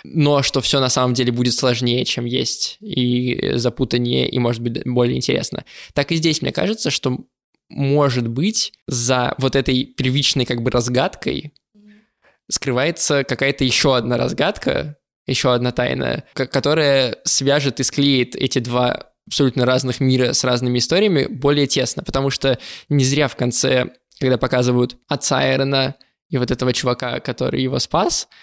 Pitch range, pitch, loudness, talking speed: 125-140 Hz, 130 Hz, -18 LUFS, 150 wpm